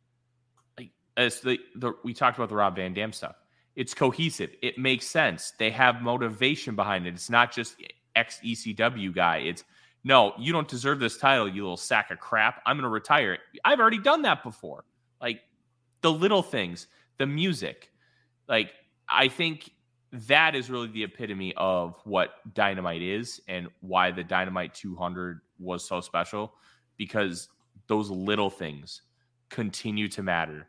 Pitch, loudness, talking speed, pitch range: 115 Hz, -26 LUFS, 155 wpm, 95-125 Hz